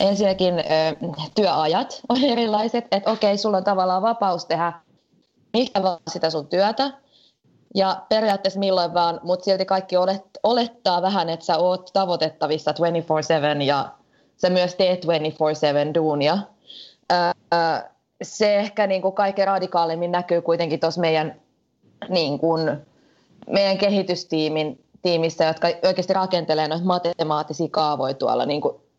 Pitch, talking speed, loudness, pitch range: 180 Hz, 120 wpm, -21 LUFS, 160-195 Hz